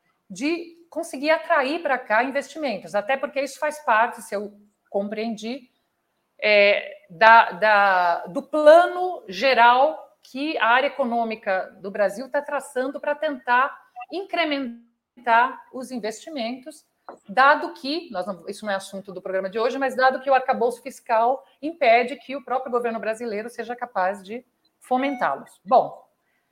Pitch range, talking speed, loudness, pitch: 215-285 Hz, 140 wpm, -22 LUFS, 250 Hz